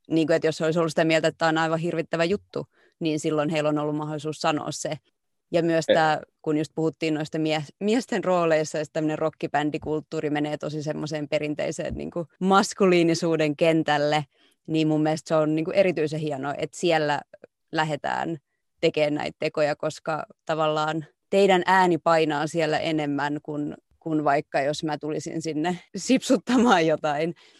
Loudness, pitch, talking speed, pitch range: -24 LUFS, 155 Hz, 160 wpm, 150-165 Hz